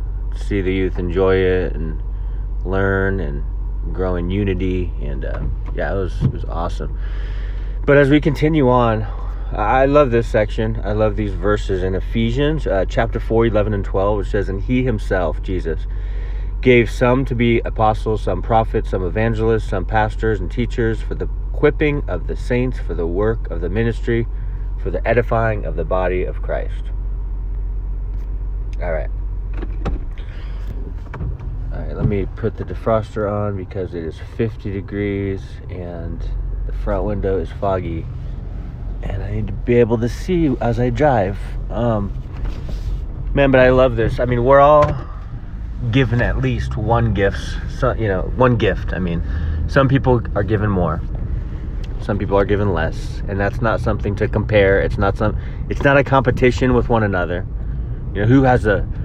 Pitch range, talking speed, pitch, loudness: 95-115 Hz, 165 wpm, 105 Hz, -19 LUFS